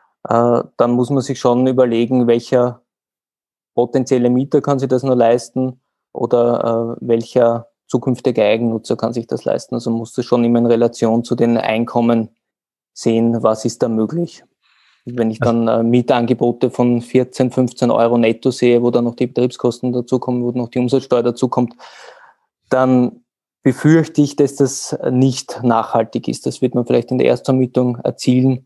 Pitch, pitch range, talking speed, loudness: 120 Hz, 115-130 Hz, 160 wpm, -16 LUFS